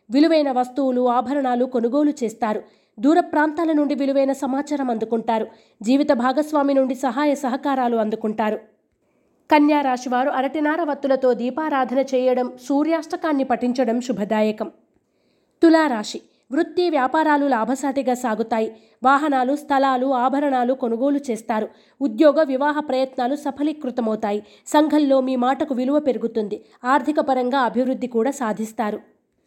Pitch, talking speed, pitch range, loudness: 265 Hz, 100 wpm, 245-290 Hz, -20 LUFS